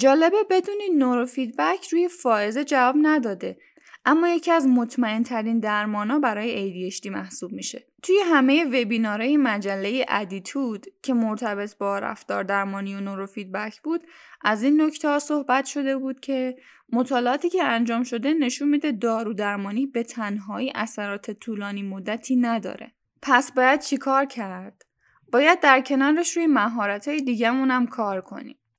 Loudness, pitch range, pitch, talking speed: -23 LUFS, 210-290 Hz, 250 Hz, 140 wpm